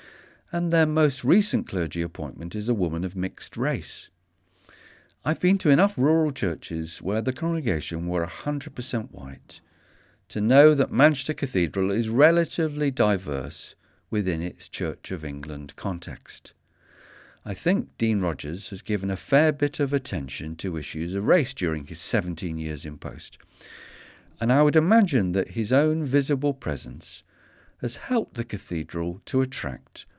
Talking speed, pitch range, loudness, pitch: 145 wpm, 85-145 Hz, -25 LUFS, 100 Hz